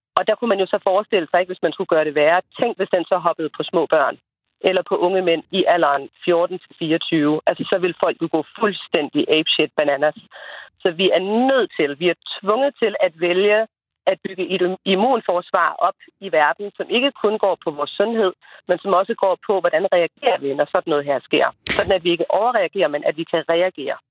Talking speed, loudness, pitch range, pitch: 215 wpm, -19 LUFS, 165-200 Hz, 185 Hz